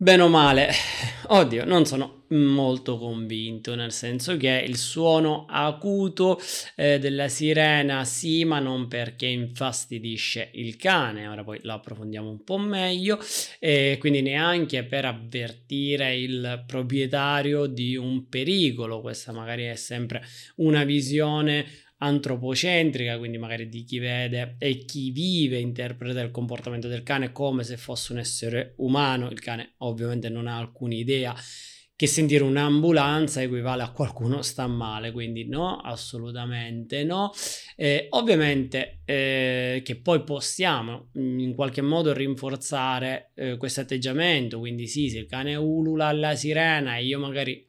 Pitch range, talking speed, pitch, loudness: 120-145 Hz, 140 wpm, 130 Hz, -25 LUFS